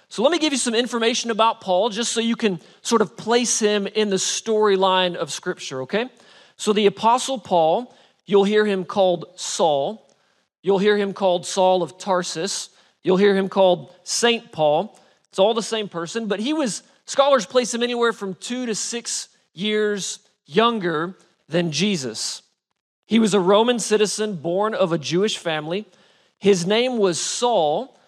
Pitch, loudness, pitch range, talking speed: 205 Hz, -21 LUFS, 185-230 Hz, 170 wpm